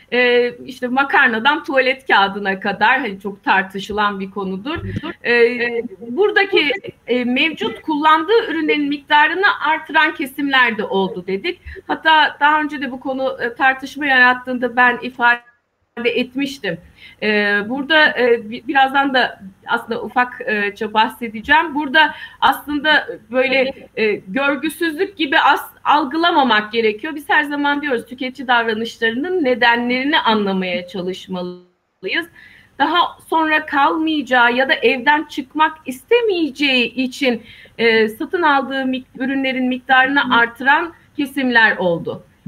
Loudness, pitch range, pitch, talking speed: -16 LUFS, 230-300 Hz, 260 Hz, 100 wpm